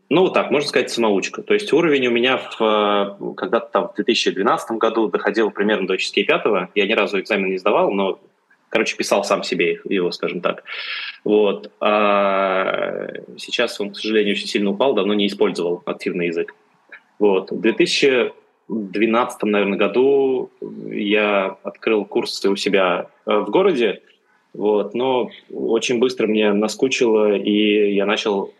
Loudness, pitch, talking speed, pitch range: -19 LUFS, 110 Hz, 150 wpm, 100-140 Hz